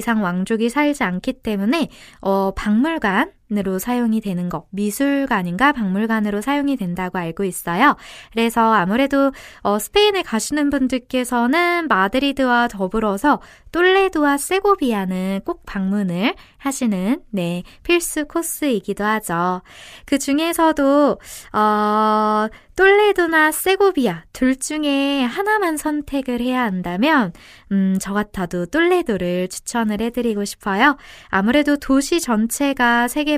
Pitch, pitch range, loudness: 240 Hz, 205-290 Hz, -19 LUFS